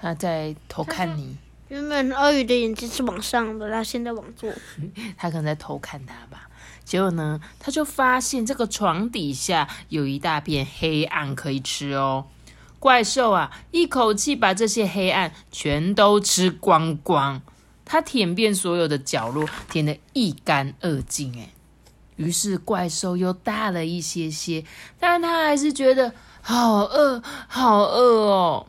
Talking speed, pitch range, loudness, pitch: 215 characters per minute, 155-240 Hz, -22 LUFS, 195 Hz